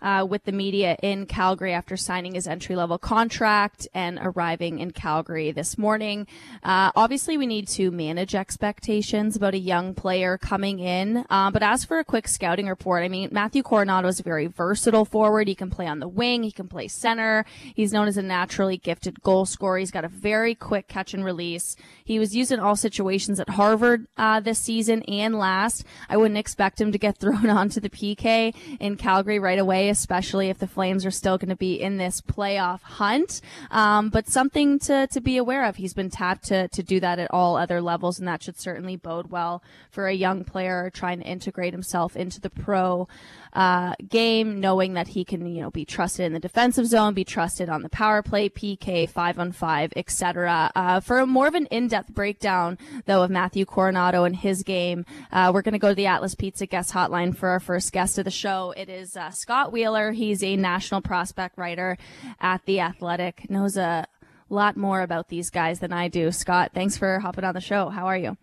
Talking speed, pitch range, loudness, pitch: 210 wpm, 180-210 Hz, -24 LUFS, 190 Hz